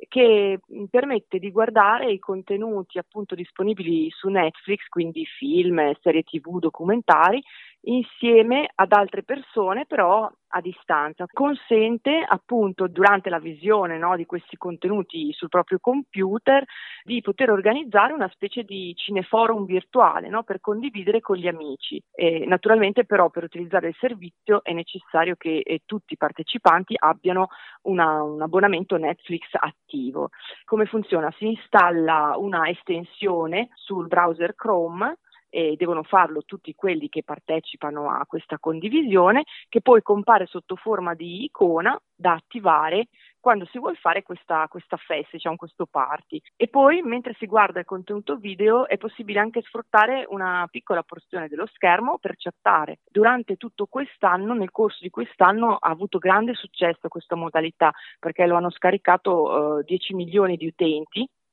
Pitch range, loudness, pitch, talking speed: 170-220 Hz, -22 LUFS, 190 Hz, 145 wpm